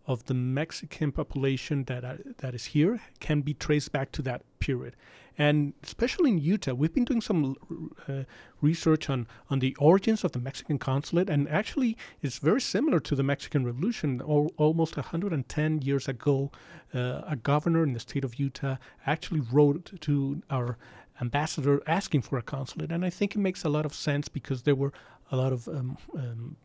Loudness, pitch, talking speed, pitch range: -29 LUFS, 145 Hz, 185 wpm, 135-160 Hz